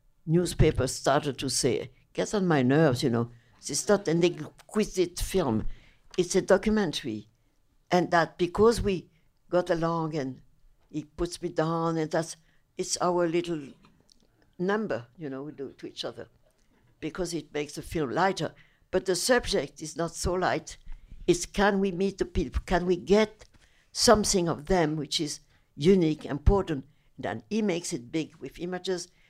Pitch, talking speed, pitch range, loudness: 165 Hz, 165 wpm, 145-180 Hz, -28 LUFS